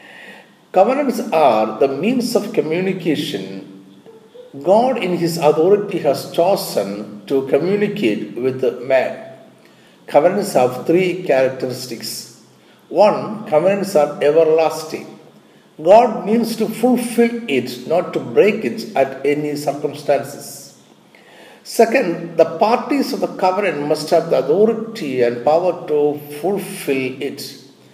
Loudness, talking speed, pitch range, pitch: -17 LUFS, 110 wpm, 140-215 Hz, 170 Hz